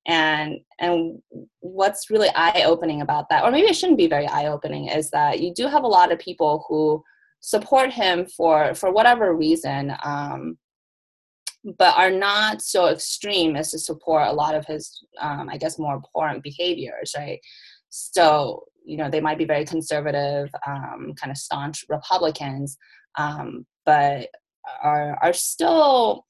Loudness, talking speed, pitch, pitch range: -21 LUFS, 160 wpm, 155 Hz, 150-185 Hz